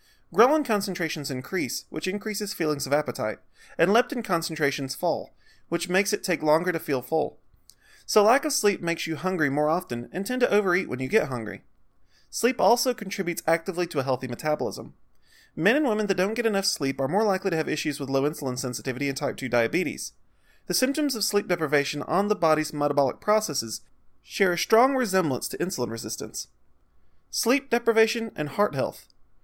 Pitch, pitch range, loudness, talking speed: 170 Hz, 140-210 Hz, -25 LUFS, 180 wpm